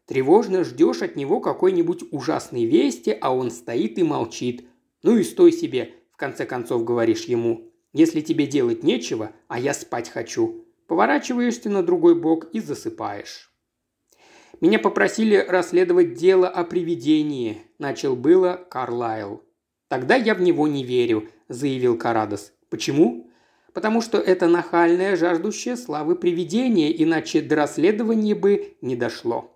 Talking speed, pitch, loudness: 135 wpm, 200 Hz, -21 LUFS